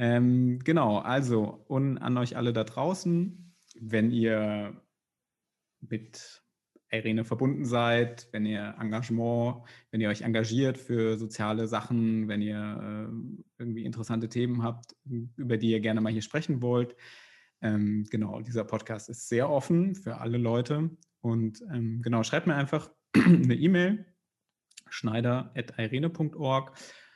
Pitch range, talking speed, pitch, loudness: 110-135 Hz, 130 wpm, 120 Hz, -29 LUFS